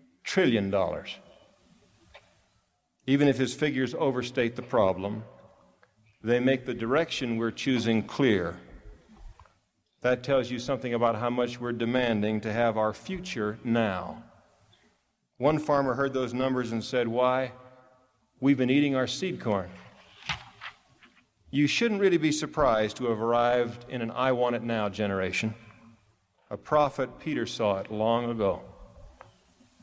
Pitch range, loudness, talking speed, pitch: 115-130 Hz, -28 LUFS, 135 wpm, 120 Hz